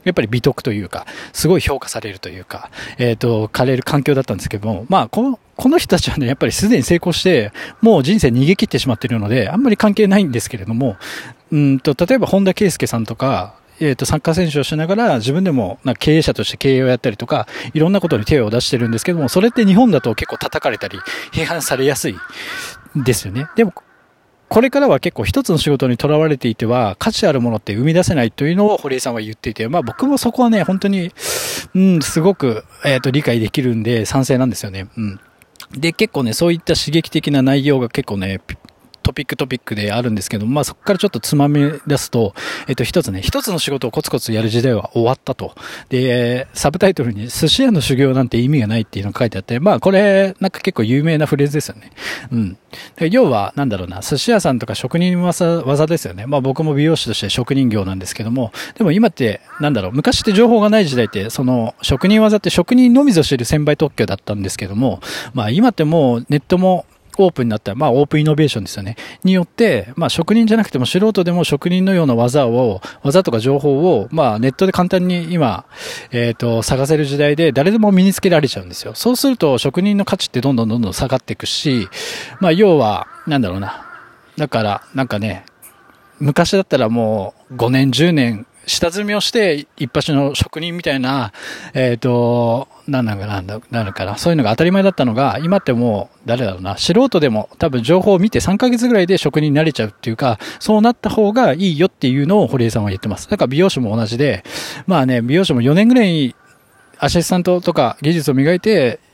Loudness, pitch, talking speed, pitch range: -16 LUFS, 140 Hz, 440 characters per minute, 120-180 Hz